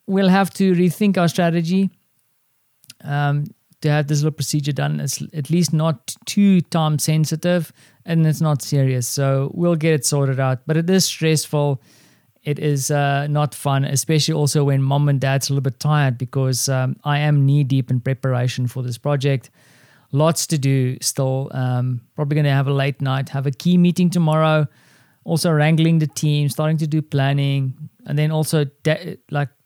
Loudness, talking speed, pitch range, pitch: -19 LUFS, 180 wpm, 135-160 Hz, 145 Hz